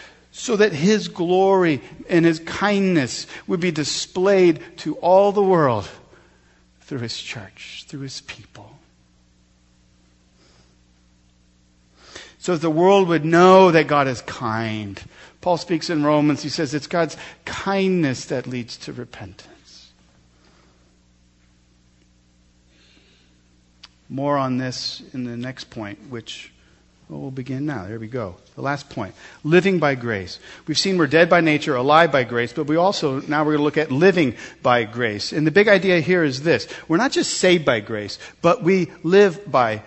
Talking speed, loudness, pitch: 155 wpm, -19 LUFS, 140 Hz